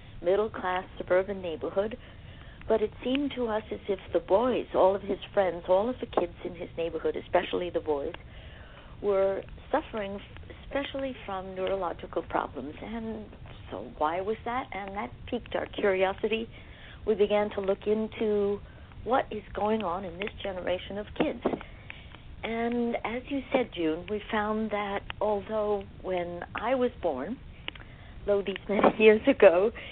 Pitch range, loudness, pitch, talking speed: 190-225 Hz, -29 LUFS, 205 Hz, 150 wpm